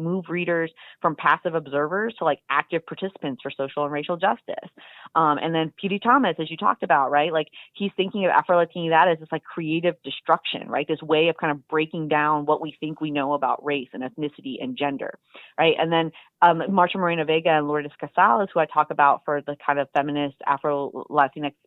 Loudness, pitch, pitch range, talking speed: -23 LUFS, 155 Hz, 145-170 Hz, 210 wpm